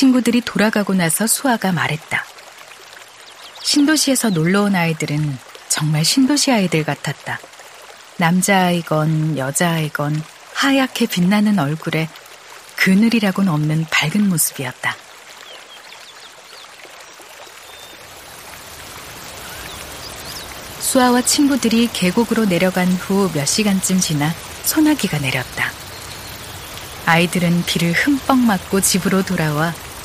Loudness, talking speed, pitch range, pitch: -17 LUFS, 235 characters per minute, 155-220 Hz, 180 Hz